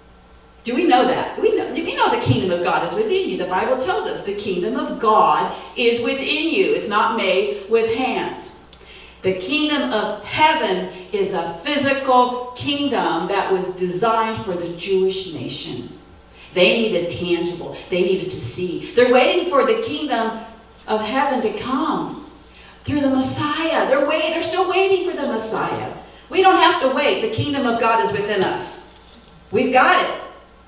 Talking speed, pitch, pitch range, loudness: 170 wpm, 250 Hz, 200-315 Hz, -19 LUFS